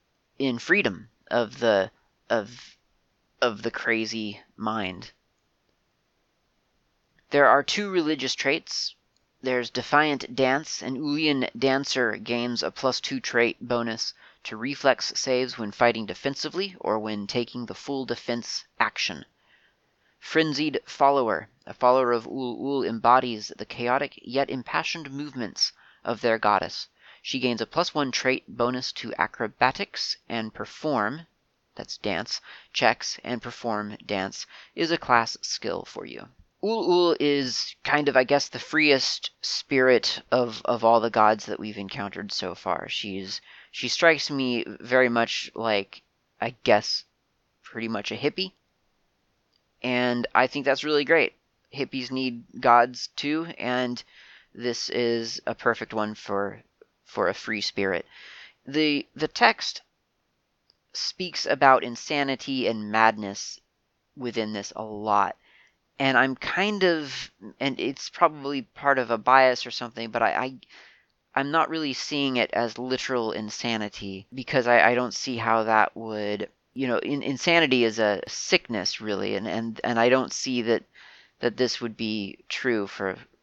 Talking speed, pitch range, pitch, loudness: 140 wpm, 115-140 Hz, 125 Hz, -25 LUFS